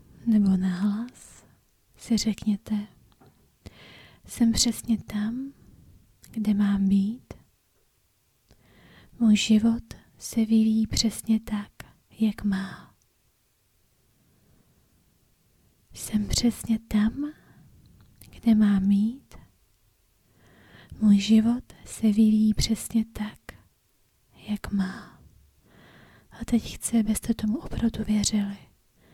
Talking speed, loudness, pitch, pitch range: 80 wpm, -25 LUFS, 215 Hz, 200-225 Hz